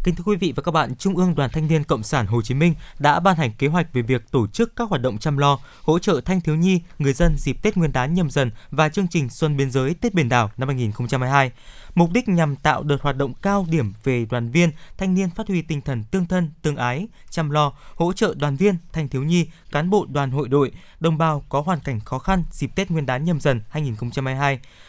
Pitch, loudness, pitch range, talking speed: 150 Hz, -21 LUFS, 135-175 Hz, 255 wpm